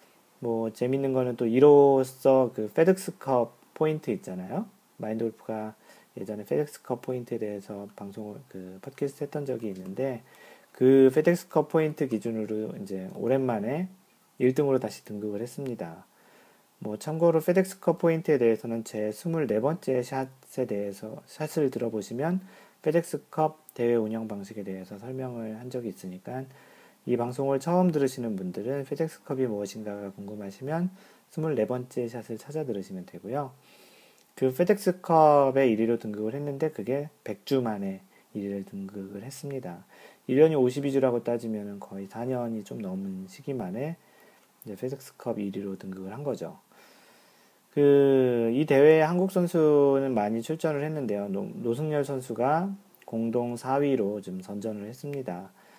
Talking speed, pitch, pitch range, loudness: 300 characters per minute, 130 Hz, 110-155 Hz, -27 LUFS